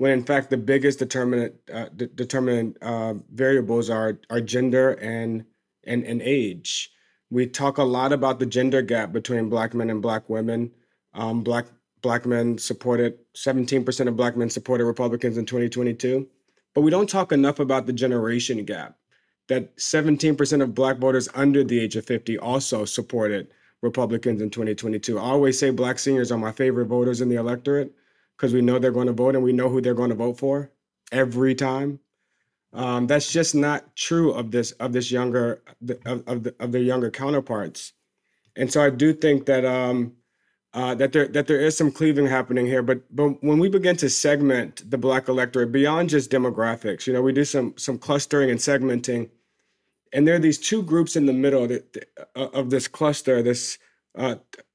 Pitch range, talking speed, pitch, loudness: 120-135 Hz, 185 wpm, 125 Hz, -23 LUFS